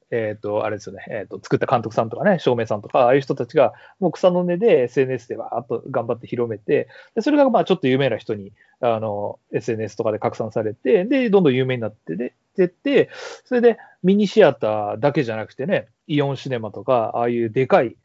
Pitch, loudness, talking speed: 135 Hz, -20 LUFS, 425 characters per minute